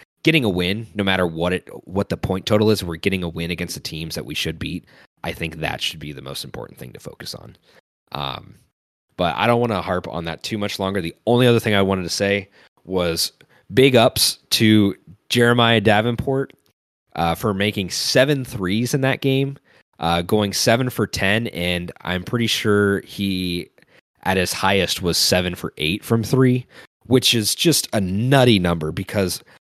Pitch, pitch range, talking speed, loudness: 100 Hz, 90-120 Hz, 190 wpm, -20 LUFS